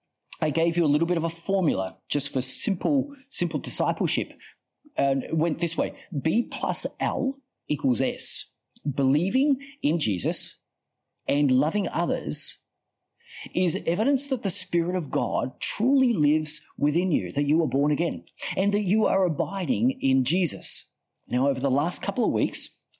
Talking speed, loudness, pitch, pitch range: 155 wpm, -25 LUFS, 170 Hz, 145-215 Hz